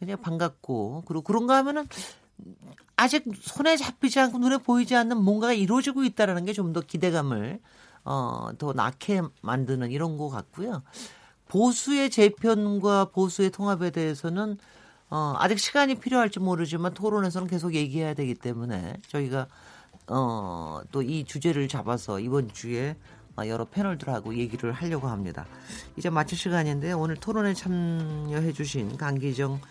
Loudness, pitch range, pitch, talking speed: -27 LUFS, 140-205 Hz, 170 Hz, 325 characters per minute